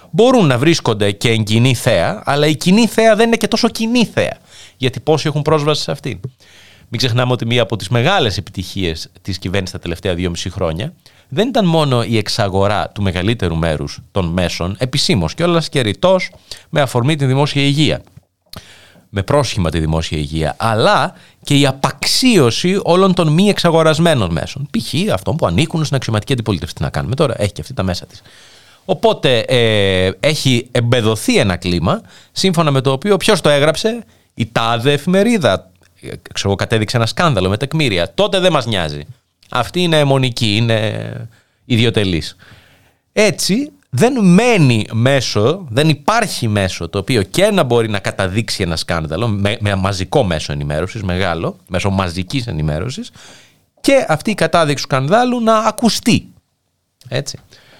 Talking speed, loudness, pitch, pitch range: 160 wpm, -15 LUFS, 125 Hz, 100-160 Hz